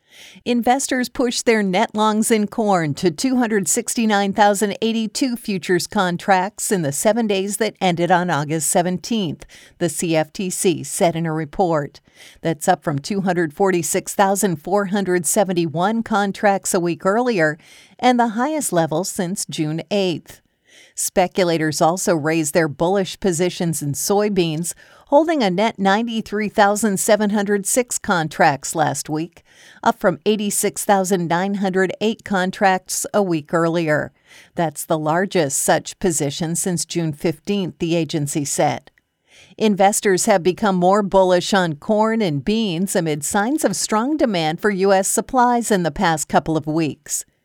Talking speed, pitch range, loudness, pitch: 125 wpm, 170-210 Hz, -19 LUFS, 190 Hz